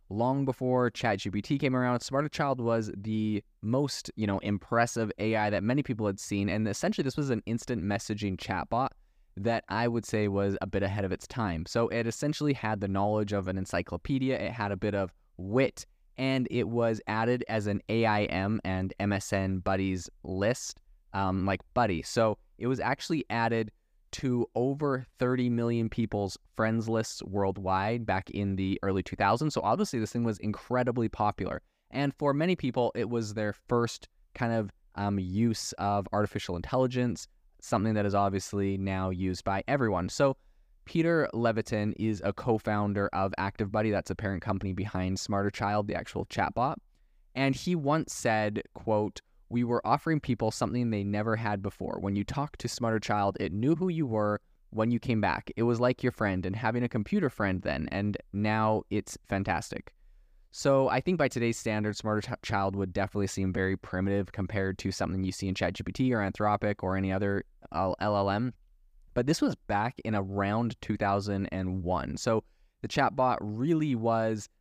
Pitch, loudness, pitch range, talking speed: 105 Hz, -30 LUFS, 100-120 Hz, 175 wpm